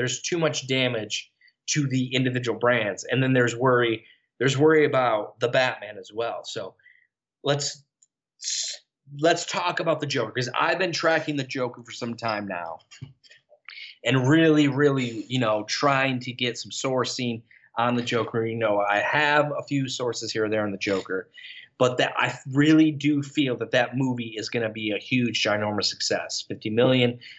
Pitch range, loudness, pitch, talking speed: 115-145 Hz, -24 LUFS, 130 Hz, 175 wpm